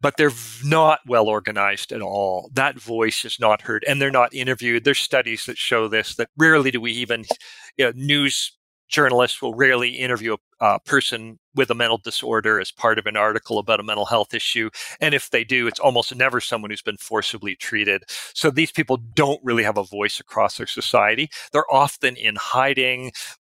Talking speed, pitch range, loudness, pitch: 195 wpm, 110-135 Hz, -20 LUFS, 120 Hz